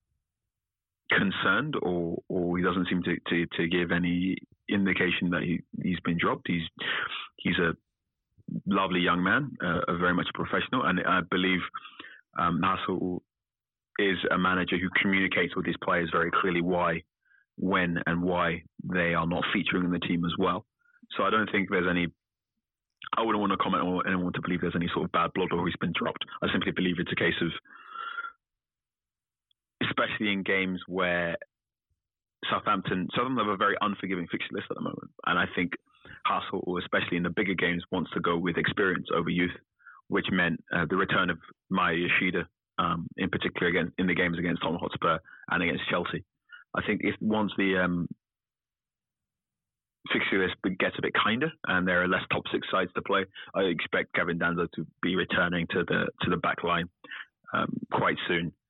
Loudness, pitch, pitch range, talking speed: -28 LUFS, 90 Hz, 85-95 Hz, 180 wpm